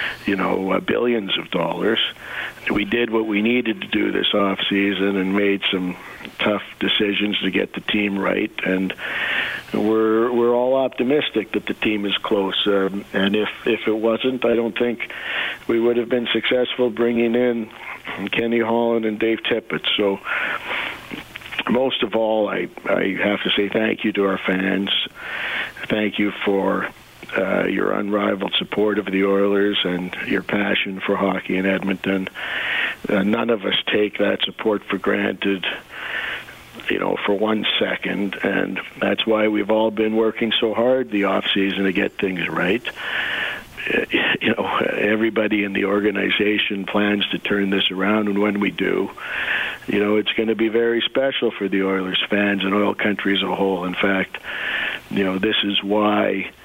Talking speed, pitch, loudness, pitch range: 165 wpm, 105 Hz, -20 LUFS, 100-110 Hz